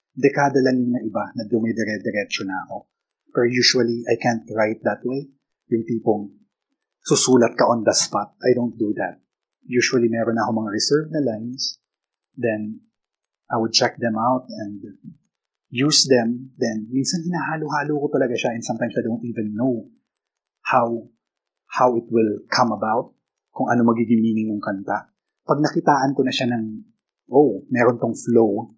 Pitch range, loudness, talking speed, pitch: 115-130 Hz, -21 LUFS, 160 wpm, 120 Hz